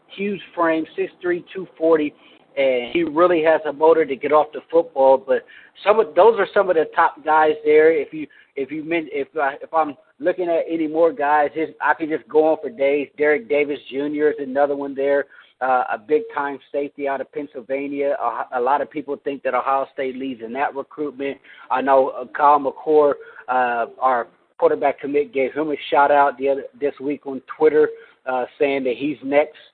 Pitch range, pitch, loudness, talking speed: 140-160 Hz, 145 Hz, -20 LUFS, 205 wpm